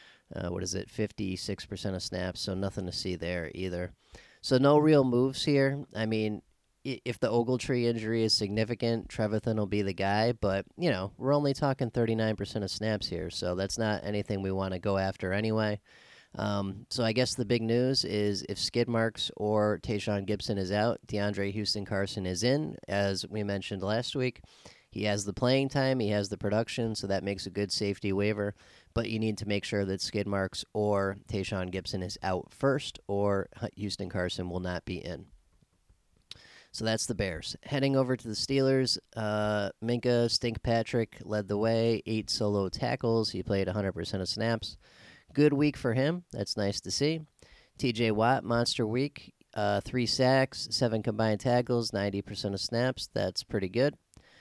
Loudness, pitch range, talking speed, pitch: -30 LUFS, 100-120 Hz, 175 wpm, 105 Hz